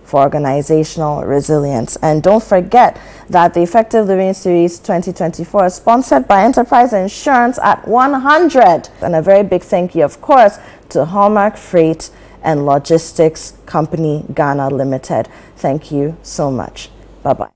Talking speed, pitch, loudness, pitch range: 140 wpm, 175 Hz, -13 LUFS, 155-210 Hz